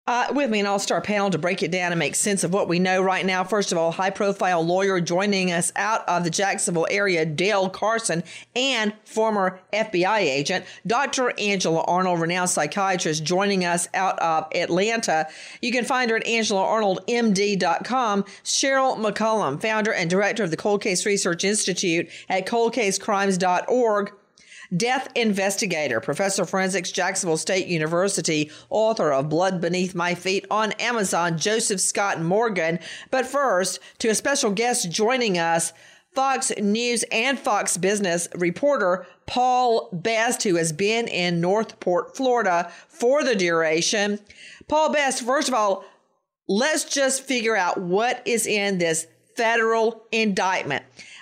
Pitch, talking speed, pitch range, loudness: 200 Hz, 150 wpm, 180-225 Hz, -22 LUFS